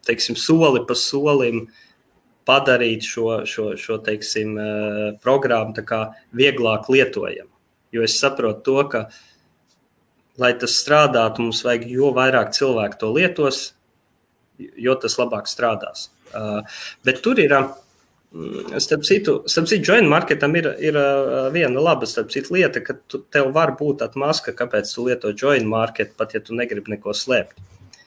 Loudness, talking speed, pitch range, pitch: -19 LUFS, 110 wpm, 110-140 Hz, 125 Hz